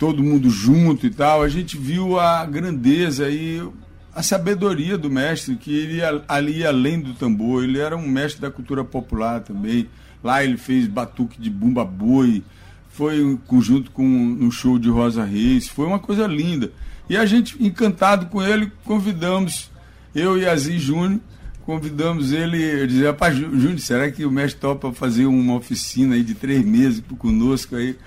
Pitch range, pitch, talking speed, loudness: 125-175 Hz, 145 Hz, 175 wpm, -19 LUFS